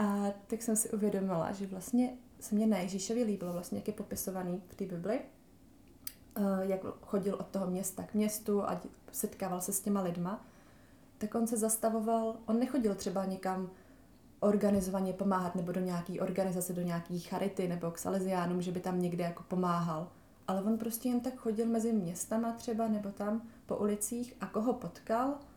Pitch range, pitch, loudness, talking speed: 185-225 Hz, 200 Hz, -35 LUFS, 175 wpm